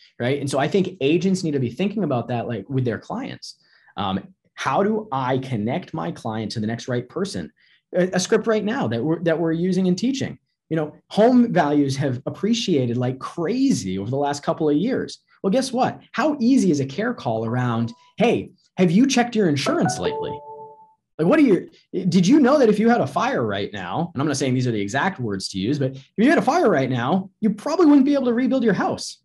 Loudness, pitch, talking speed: -21 LUFS, 170 Hz, 235 wpm